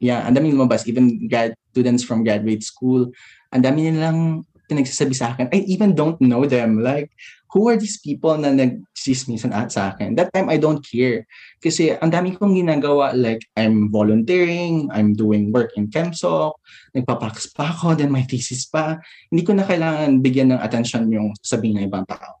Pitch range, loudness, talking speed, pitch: 115-160 Hz, -19 LUFS, 180 wpm, 130 Hz